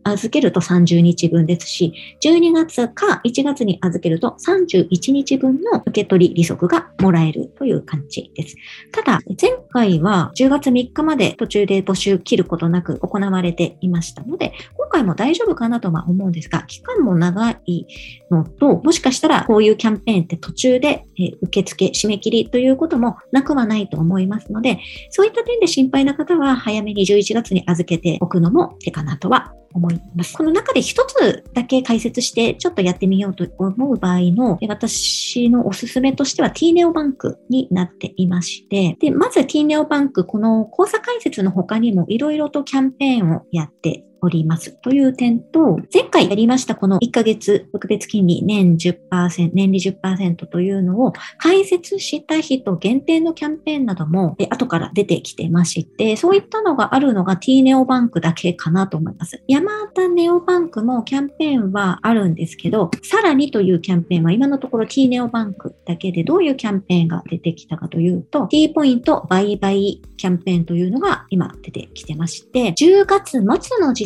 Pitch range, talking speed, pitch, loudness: 180-275 Hz, 360 characters per minute, 215 Hz, -17 LUFS